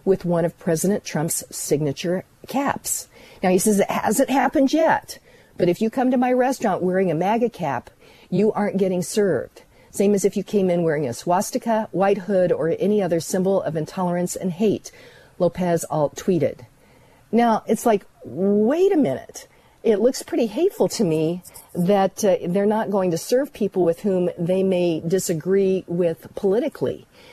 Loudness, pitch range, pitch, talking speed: -21 LUFS, 175-225 Hz, 195 Hz, 170 wpm